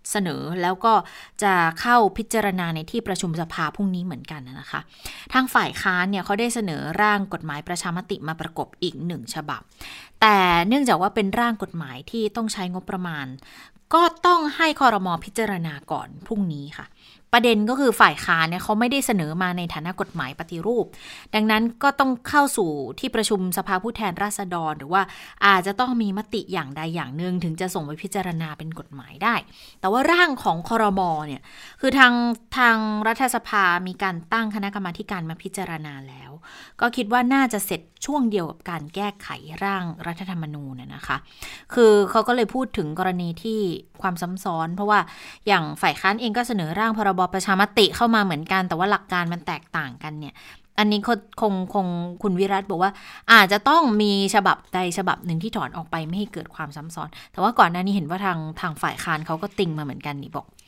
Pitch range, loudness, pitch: 170-220 Hz, -22 LUFS, 195 Hz